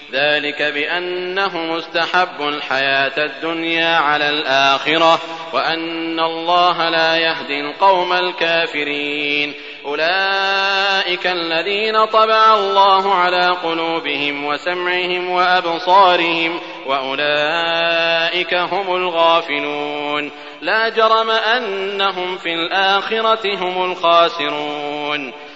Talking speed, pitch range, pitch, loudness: 75 wpm, 150-180 Hz, 165 Hz, -16 LUFS